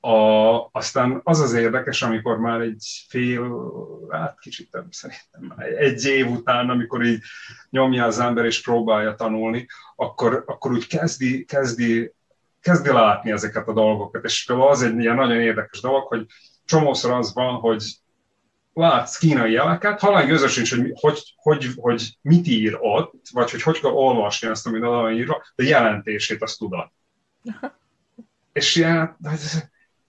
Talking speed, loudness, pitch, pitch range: 150 wpm, -20 LUFS, 120 Hz, 115-140 Hz